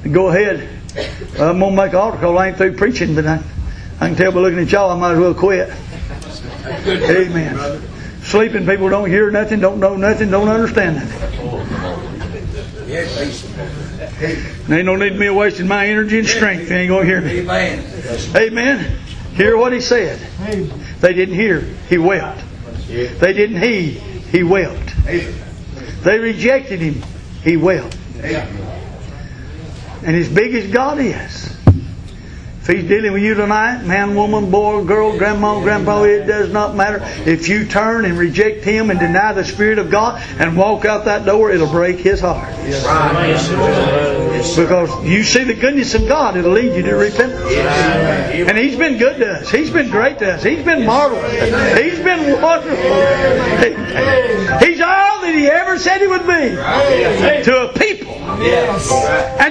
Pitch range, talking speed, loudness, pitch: 175-220 Hz, 160 wpm, -14 LUFS, 200 Hz